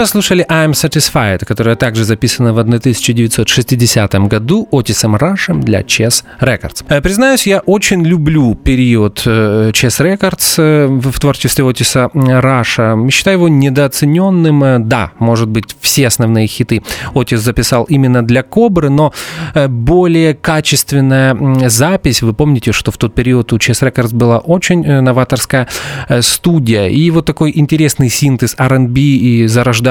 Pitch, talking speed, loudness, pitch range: 130 Hz, 130 wpm, -10 LUFS, 120-155 Hz